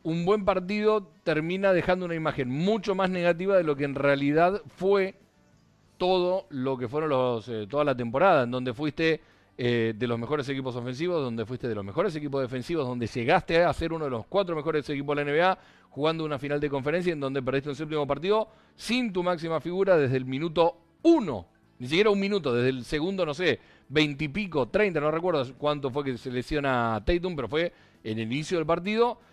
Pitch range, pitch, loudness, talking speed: 130-180 Hz, 155 Hz, -27 LUFS, 205 wpm